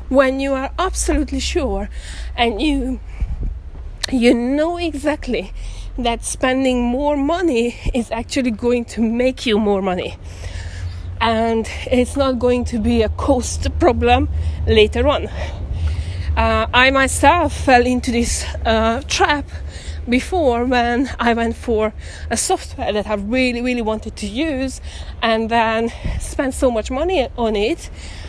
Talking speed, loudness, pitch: 135 wpm, -18 LUFS, 235 Hz